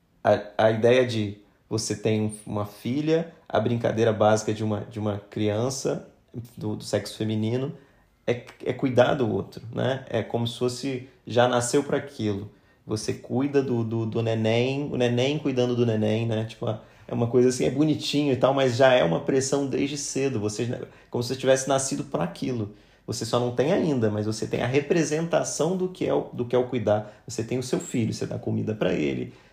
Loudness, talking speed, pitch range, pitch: -25 LUFS, 200 wpm, 110-135 Hz, 120 Hz